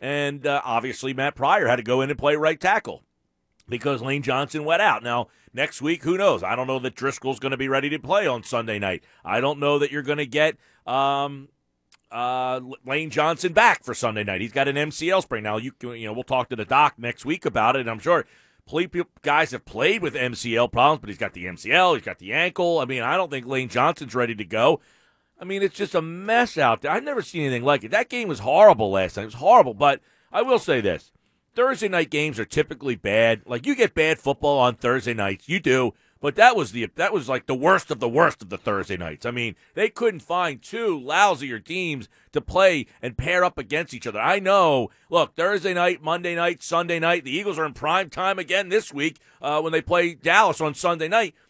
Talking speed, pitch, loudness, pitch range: 240 wpm, 145 Hz, -22 LUFS, 125-175 Hz